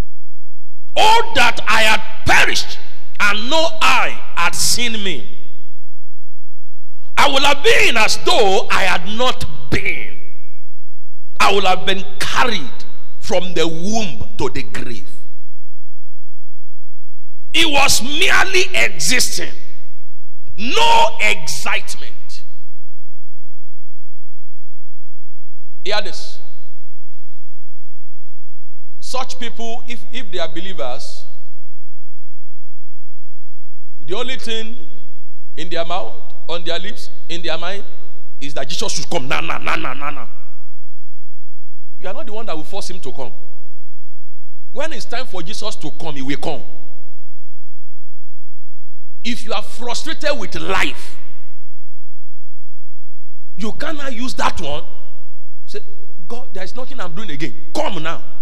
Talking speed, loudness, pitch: 115 wpm, -18 LUFS, 175 Hz